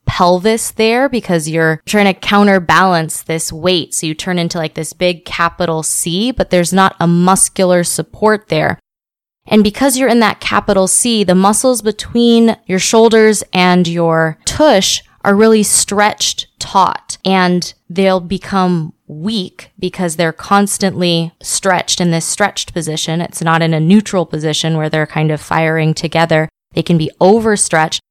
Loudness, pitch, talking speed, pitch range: -12 LUFS, 180 Hz, 155 wpm, 165-205 Hz